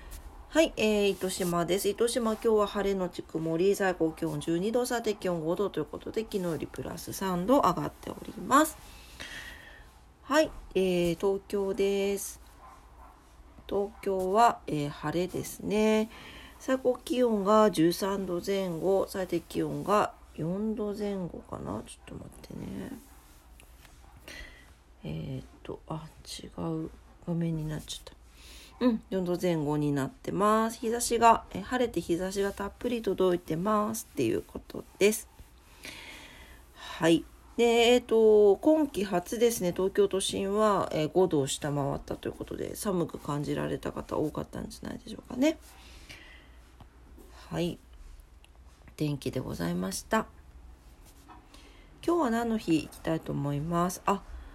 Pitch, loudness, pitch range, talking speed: 185 Hz, -29 LUFS, 145-215 Hz, 255 characters per minute